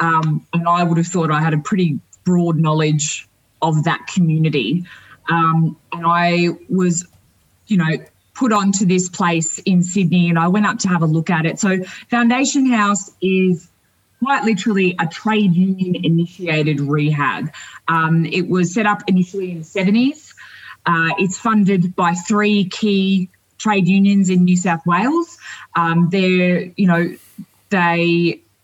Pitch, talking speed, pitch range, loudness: 175 Hz, 155 wpm, 165-195 Hz, -17 LUFS